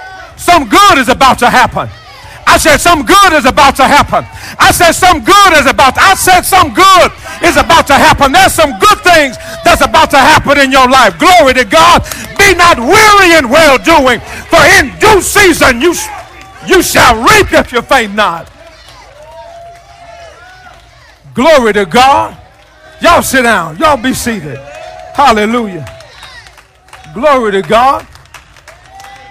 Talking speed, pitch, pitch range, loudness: 150 wpm, 315 Hz, 260-355 Hz, -6 LUFS